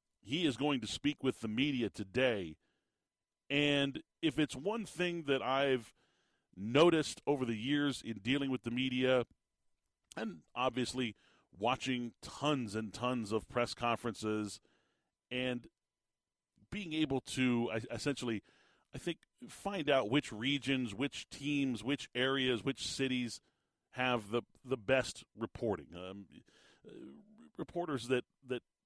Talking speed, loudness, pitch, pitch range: 125 wpm, -36 LUFS, 130 Hz, 115-140 Hz